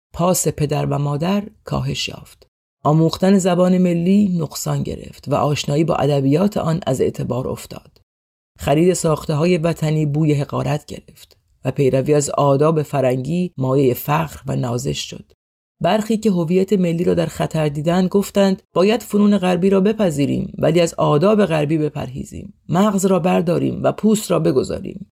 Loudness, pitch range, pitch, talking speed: -18 LUFS, 145-185 Hz, 160 Hz, 150 wpm